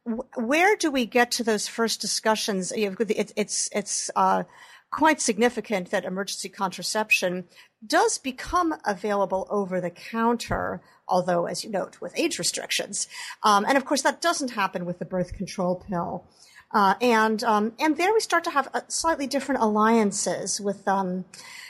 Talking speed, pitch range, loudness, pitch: 150 wpm, 195-260 Hz, -25 LUFS, 215 Hz